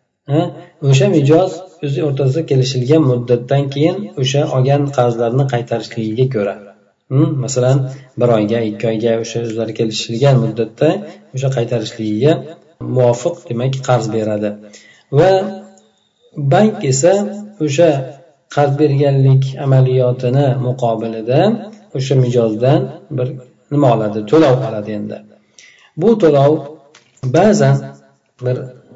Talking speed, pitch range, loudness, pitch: 95 wpm, 115-145 Hz, -15 LUFS, 130 Hz